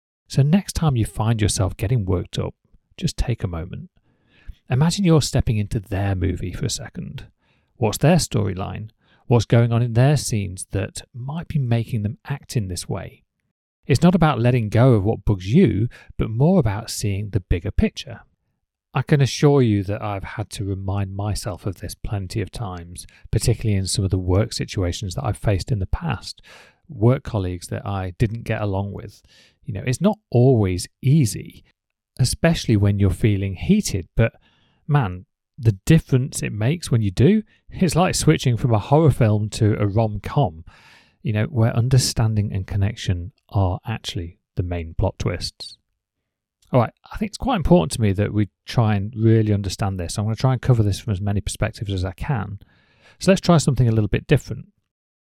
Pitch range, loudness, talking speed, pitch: 100-130 Hz, -21 LUFS, 185 wpm, 110 Hz